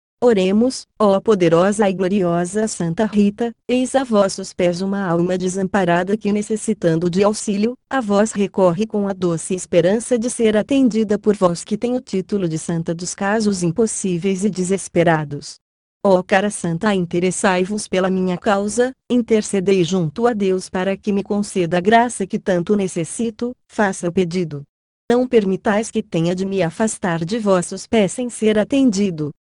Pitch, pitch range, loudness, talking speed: 200 Hz, 180-220 Hz, -18 LUFS, 155 wpm